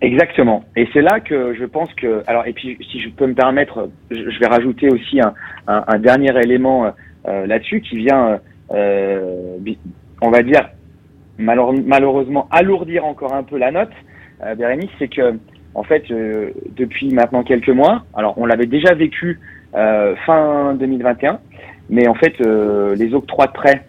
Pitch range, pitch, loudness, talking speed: 110-140 Hz, 125 Hz, -15 LUFS, 170 wpm